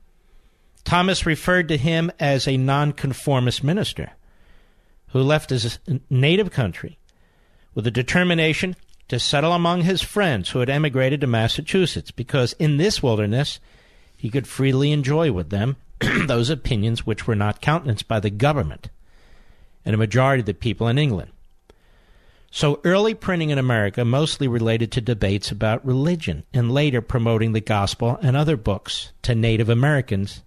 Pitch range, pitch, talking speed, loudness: 115-150 Hz, 130 Hz, 150 wpm, -21 LUFS